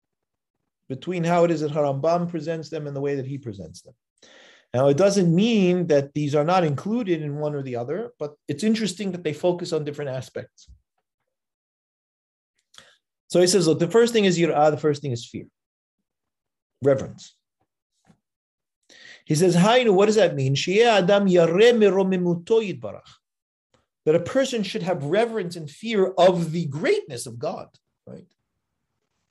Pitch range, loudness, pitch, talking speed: 145-195 Hz, -21 LUFS, 170 Hz, 155 wpm